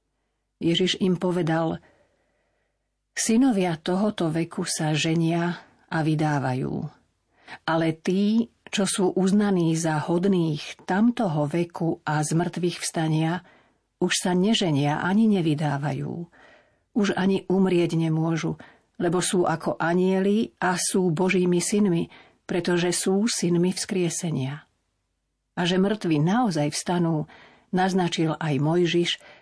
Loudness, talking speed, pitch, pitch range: -24 LUFS, 105 wpm, 175 Hz, 160-185 Hz